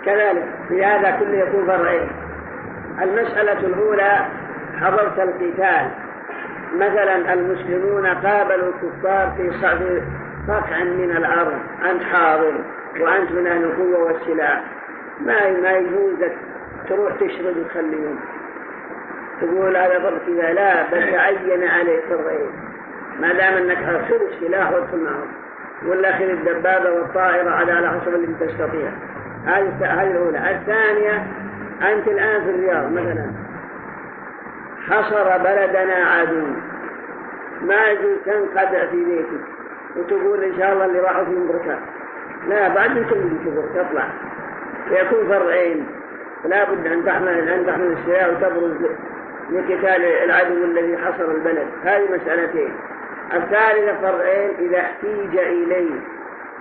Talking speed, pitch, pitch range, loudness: 105 wpm, 185 Hz, 175-200 Hz, -19 LUFS